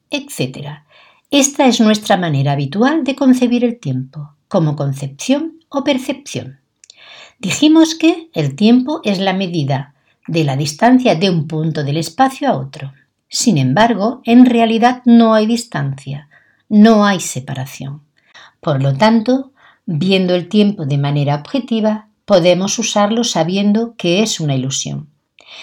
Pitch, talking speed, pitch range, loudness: 200 Hz, 135 wpm, 145-240 Hz, -14 LUFS